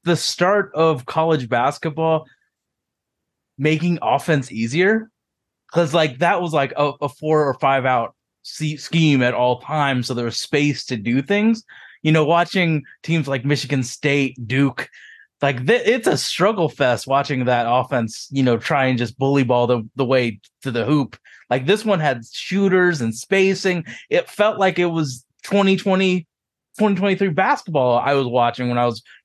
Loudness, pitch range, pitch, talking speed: -19 LUFS, 130-180 Hz, 150 Hz, 170 wpm